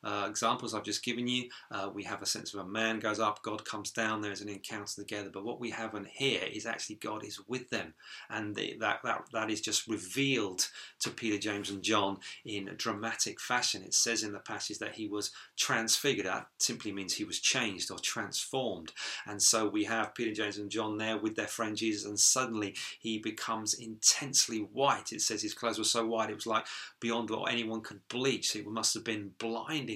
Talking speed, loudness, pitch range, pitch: 220 wpm, -33 LUFS, 105-115 Hz, 110 Hz